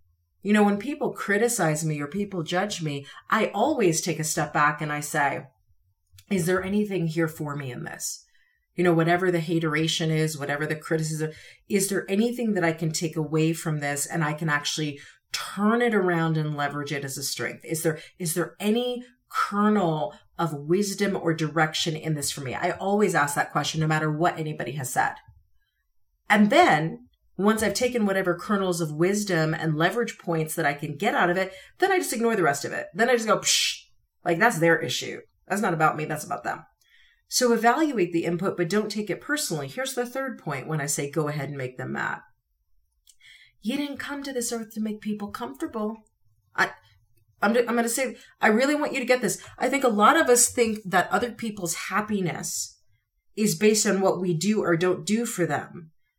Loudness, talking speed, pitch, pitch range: -25 LUFS, 205 wpm, 175 Hz, 155-210 Hz